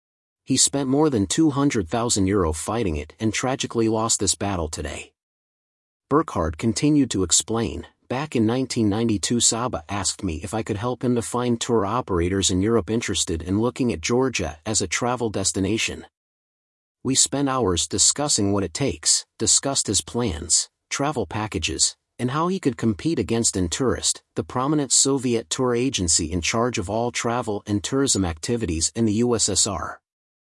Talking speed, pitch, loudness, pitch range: 155 wpm, 110 Hz, -22 LUFS, 95-125 Hz